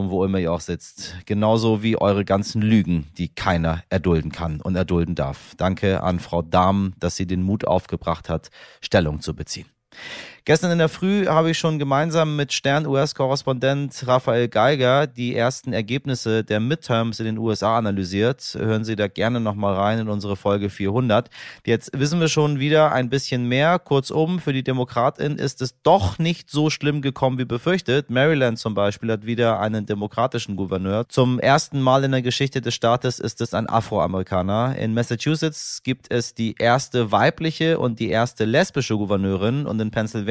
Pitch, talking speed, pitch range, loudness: 115 Hz, 175 wpm, 100-135 Hz, -21 LUFS